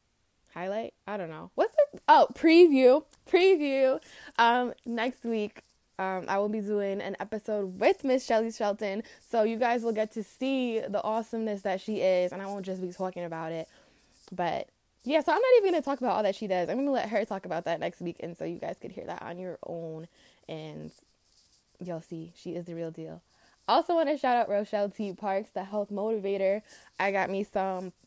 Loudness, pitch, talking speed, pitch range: -28 LUFS, 205 Hz, 205 wpm, 185-245 Hz